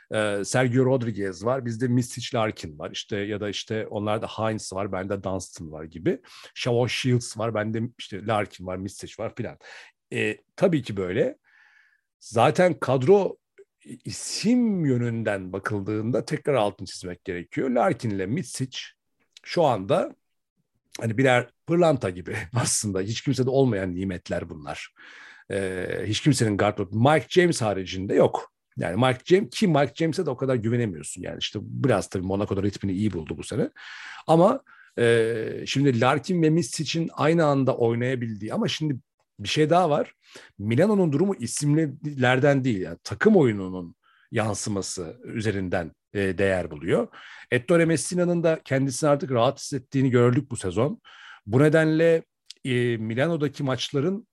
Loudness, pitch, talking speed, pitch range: -24 LUFS, 120 Hz, 140 wpm, 100-145 Hz